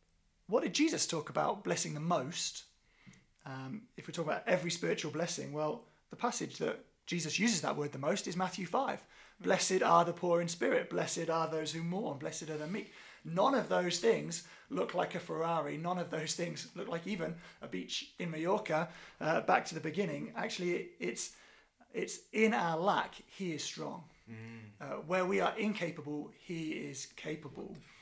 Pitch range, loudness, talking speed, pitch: 155-185 Hz, -35 LUFS, 180 wpm, 170 Hz